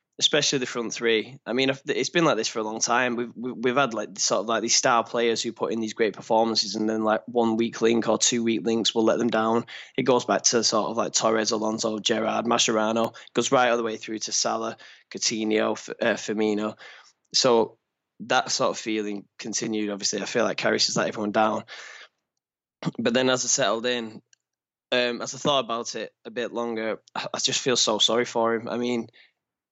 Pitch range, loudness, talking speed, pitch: 110-120 Hz, -24 LUFS, 215 wpm, 115 Hz